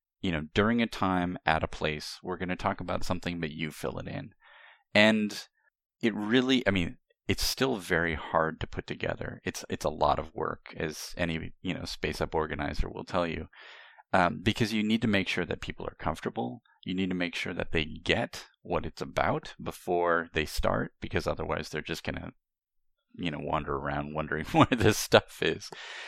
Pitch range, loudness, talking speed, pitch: 80-100 Hz, -30 LUFS, 200 wpm, 85 Hz